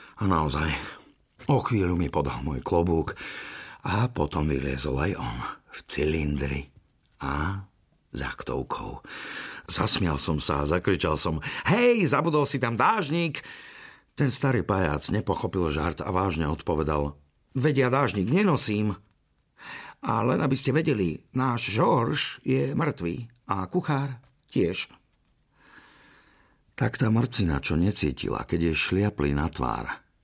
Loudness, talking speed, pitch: -26 LUFS, 120 wpm, 95 Hz